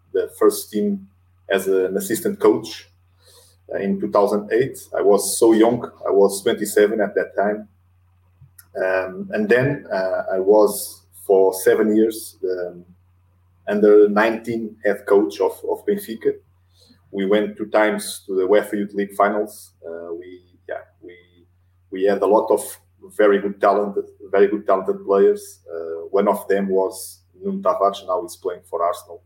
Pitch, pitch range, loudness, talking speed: 100 Hz, 90-110 Hz, -19 LUFS, 155 wpm